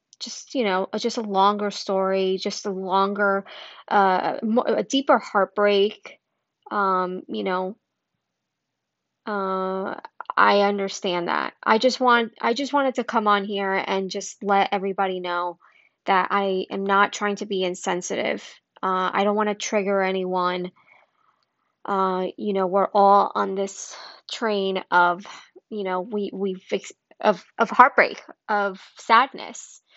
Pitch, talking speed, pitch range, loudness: 200 Hz, 140 wpm, 190-210 Hz, -22 LUFS